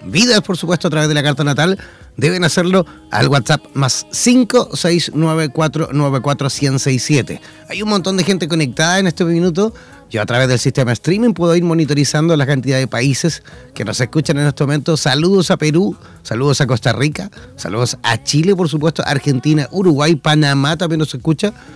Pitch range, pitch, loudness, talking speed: 140-175 Hz, 155 Hz, -15 LUFS, 170 wpm